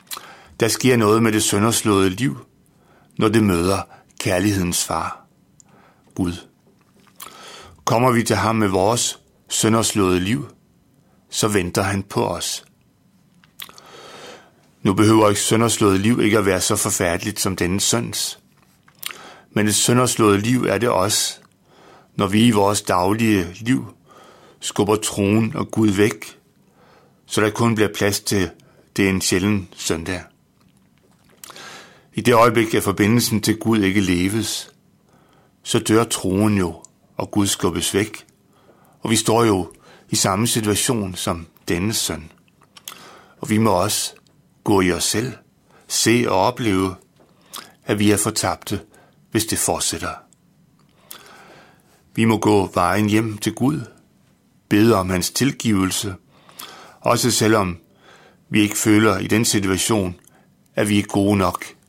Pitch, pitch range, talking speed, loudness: 105 Hz, 95-110 Hz, 130 wpm, -19 LUFS